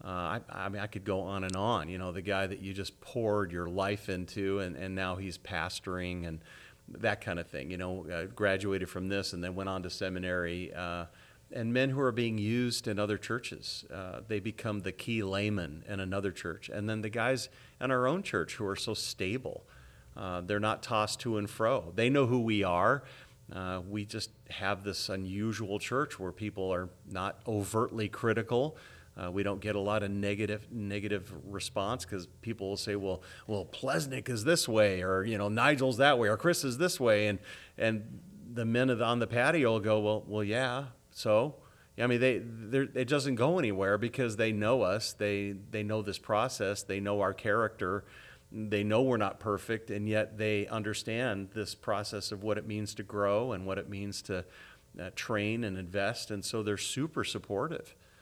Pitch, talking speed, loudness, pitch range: 105 Hz, 200 wpm, -33 LUFS, 95-115 Hz